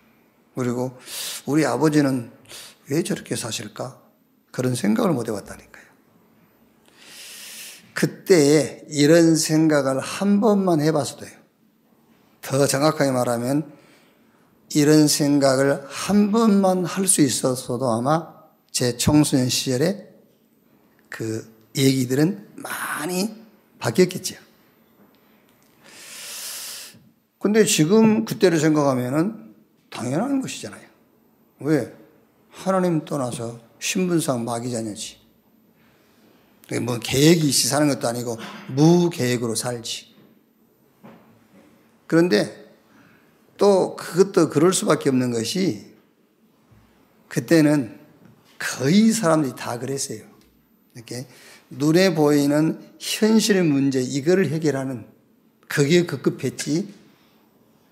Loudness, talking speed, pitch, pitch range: -21 LUFS, 205 characters per minute, 145 Hz, 125-175 Hz